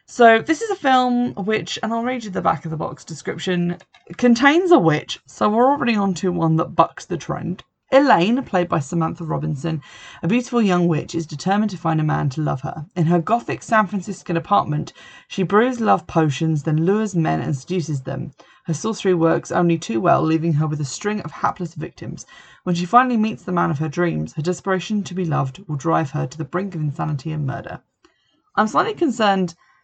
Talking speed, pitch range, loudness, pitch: 210 wpm, 160-215 Hz, -20 LUFS, 175 Hz